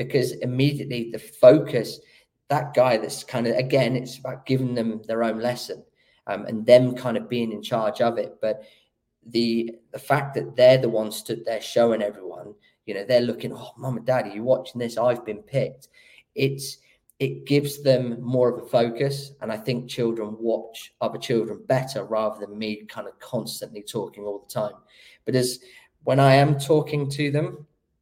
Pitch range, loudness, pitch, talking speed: 115-130 Hz, -24 LUFS, 125 Hz, 185 wpm